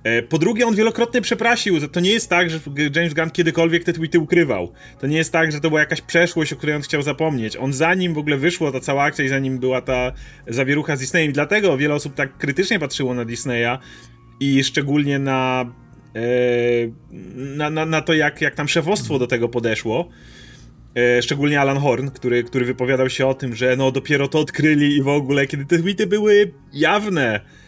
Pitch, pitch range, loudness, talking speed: 145 Hz, 130-165 Hz, -19 LUFS, 195 wpm